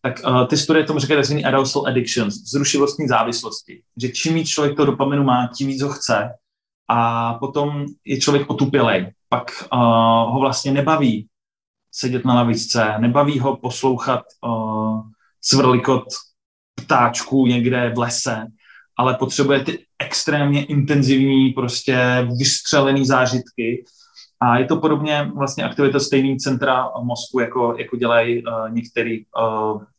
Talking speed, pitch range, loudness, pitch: 135 wpm, 120-140 Hz, -18 LUFS, 130 Hz